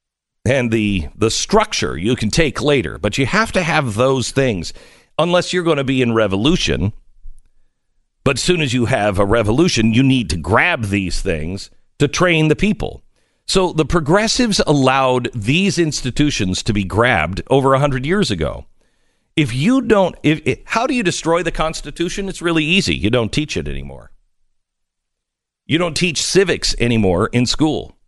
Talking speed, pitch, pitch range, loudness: 170 wpm, 135 Hz, 110-170 Hz, -16 LUFS